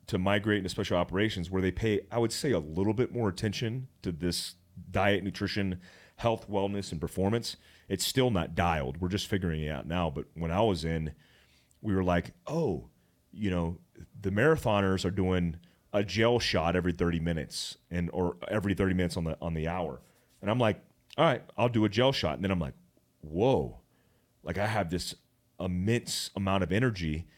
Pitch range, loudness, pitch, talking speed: 85-105 Hz, -31 LUFS, 95 Hz, 195 wpm